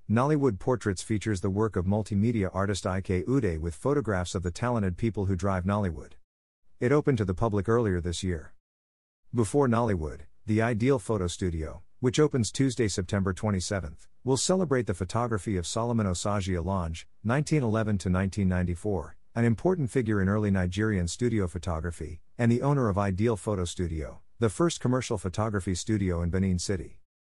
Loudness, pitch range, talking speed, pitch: -28 LUFS, 90-115 Hz, 160 wpm, 100 Hz